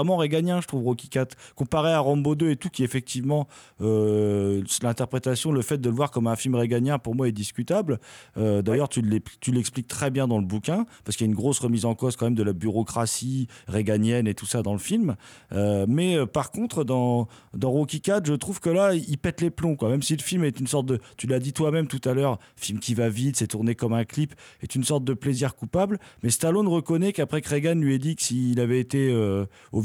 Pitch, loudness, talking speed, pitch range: 130 Hz, -25 LUFS, 240 wpm, 115-150 Hz